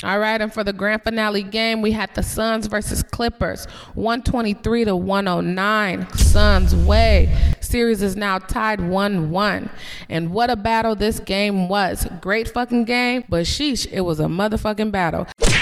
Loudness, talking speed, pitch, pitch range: -20 LUFS, 160 wpm, 205 Hz, 180-225 Hz